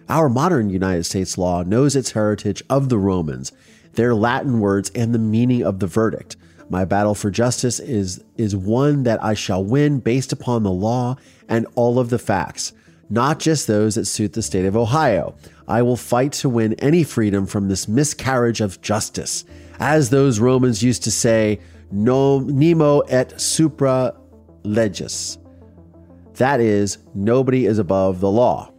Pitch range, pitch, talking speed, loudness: 95-125 Hz, 110 Hz, 165 wpm, -19 LUFS